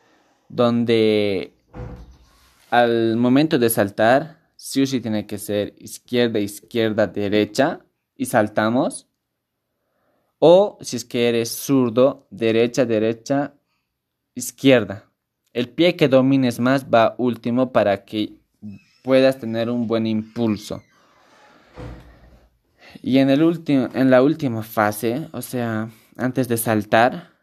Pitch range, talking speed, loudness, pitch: 110-130 Hz, 110 wpm, -19 LUFS, 120 Hz